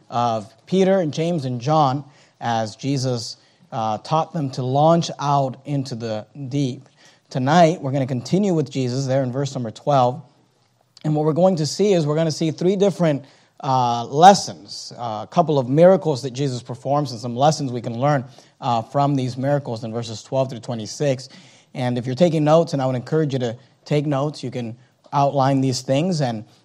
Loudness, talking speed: -20 LUFS, 195 wpm